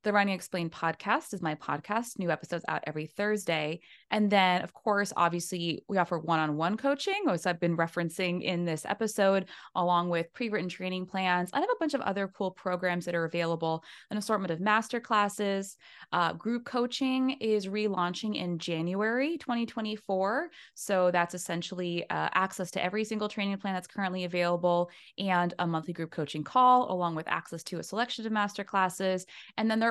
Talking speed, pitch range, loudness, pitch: 185 wpm, 175-215 Hz, -30 LUFS, 185 Hz